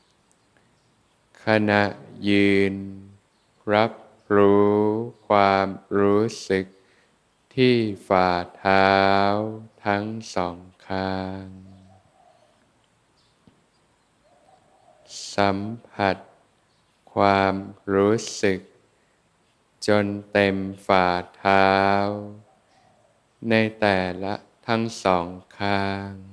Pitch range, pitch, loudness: 95-105 Hz, 100 Hz, -22 LUFS